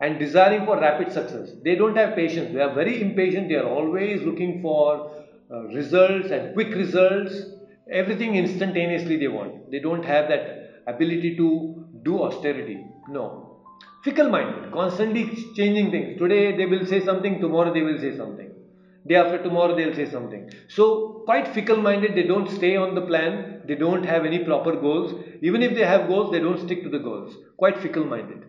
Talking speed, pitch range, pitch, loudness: 185 wpm, 160-200 Hz, 180 Hz, -22 LUFS